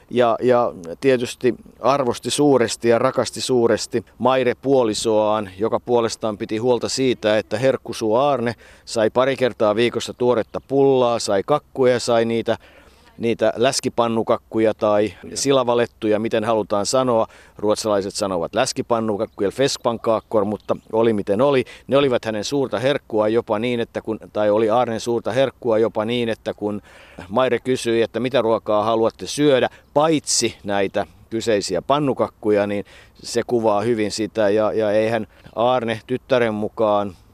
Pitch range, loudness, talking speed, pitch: 105-125 Hz, -20 LUFS, 135 wpm, 115 Hz